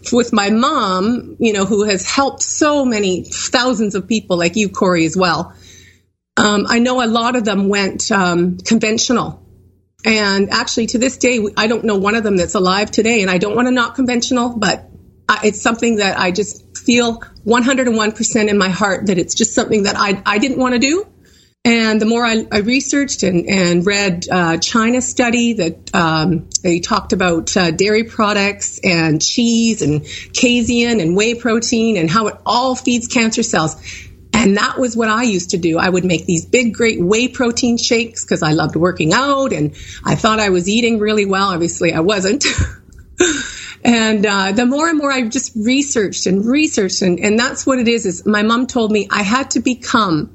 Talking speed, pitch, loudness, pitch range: 195 wpm, 215 Hz, -15 LUFS, 185-240 Hz